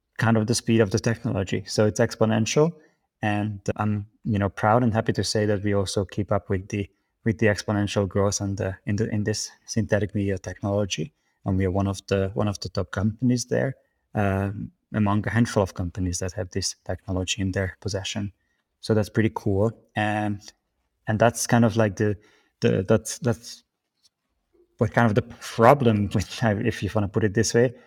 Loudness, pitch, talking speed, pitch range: -24 LUFS, 105 Hz, 200 wpm, 100-115 Hz